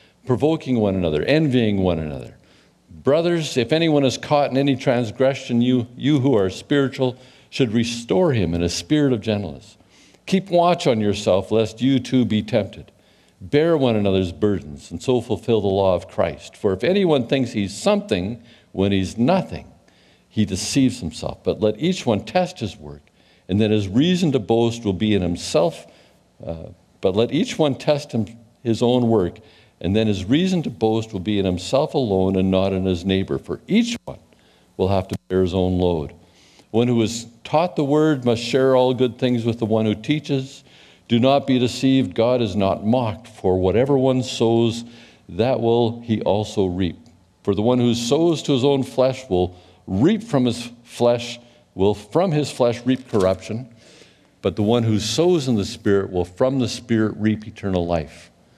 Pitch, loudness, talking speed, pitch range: 115 Hz, -20 LUFS, 185 wpm, 95-130 Hz